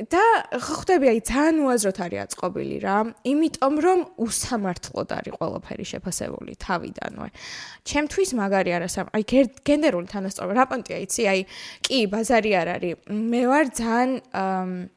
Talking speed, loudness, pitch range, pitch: 130 wpm, -23 LUFS, 190-270 Hz, 230 Hz